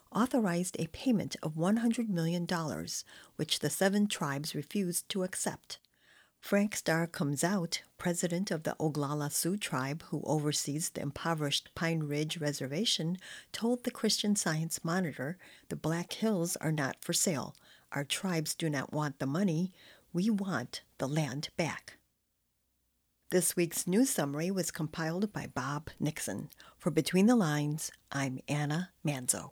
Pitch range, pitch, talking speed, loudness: 145-190 Hz, 165 Hz, 140 wpm, -33 LUFS